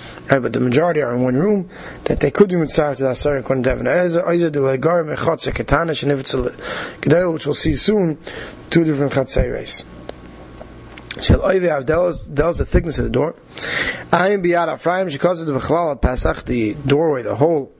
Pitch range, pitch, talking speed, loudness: 135-170 Hz, 150 Hz, 210 wpm, -18 LUFS